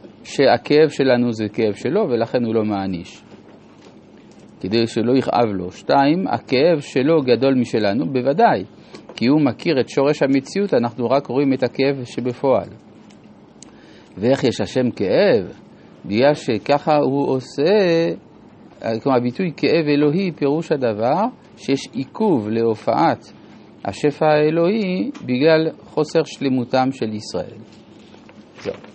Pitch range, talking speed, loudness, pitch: 120-150 Hz, 115 wpm, -18 LUFS, 135 Hz